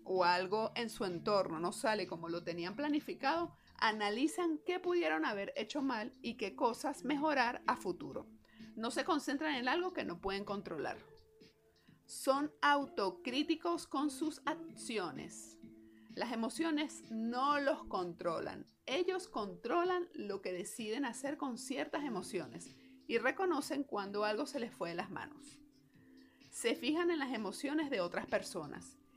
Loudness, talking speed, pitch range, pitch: -38 LUFS, 140 wpm, 205-300 Hz, 270 Hz